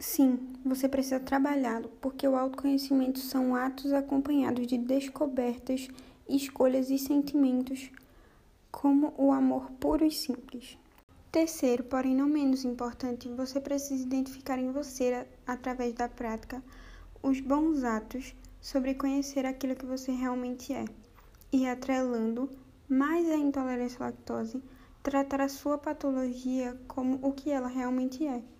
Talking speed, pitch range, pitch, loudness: 130 wpm, 255-275 Hz, 265 Hz, -31 LUFS